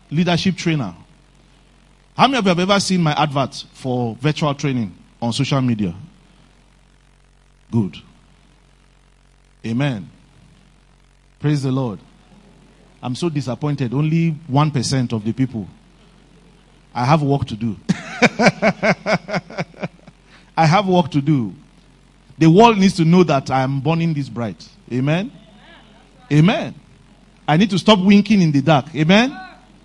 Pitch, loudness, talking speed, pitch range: 155 Hz, -18 LUFS, 125 wpm, 135-185 Hz